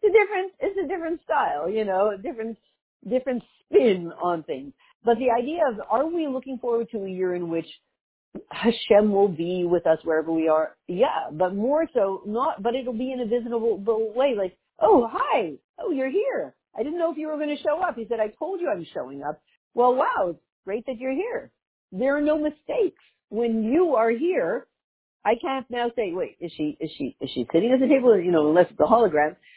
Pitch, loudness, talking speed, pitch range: 235 Hz, -24 LUFS, 220 wpm, 185-300 Hz